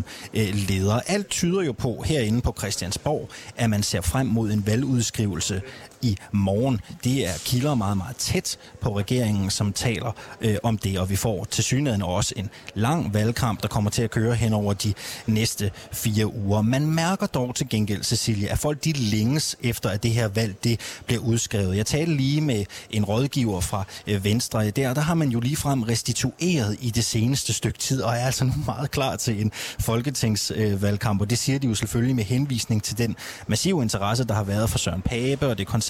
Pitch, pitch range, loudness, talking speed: 115 Hz, 105-130 Hz, -24 LUFS, 195 wpm